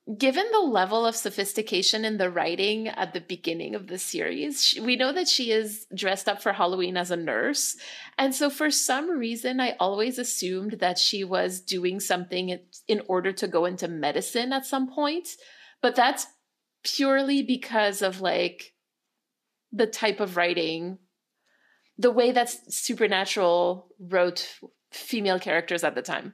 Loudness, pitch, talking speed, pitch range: -25 LUFS, 210 Hz, 155 wpm, 185-255 Hz